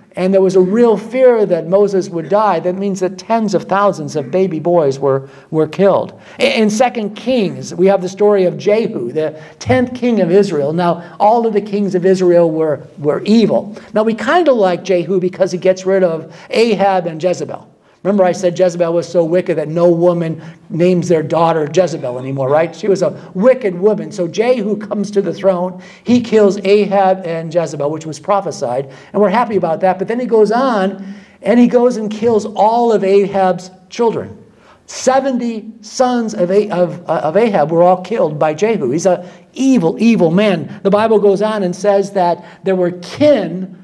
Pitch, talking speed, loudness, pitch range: 190 Hz, 190 wpm, -14 LUFS, 175-210 Hz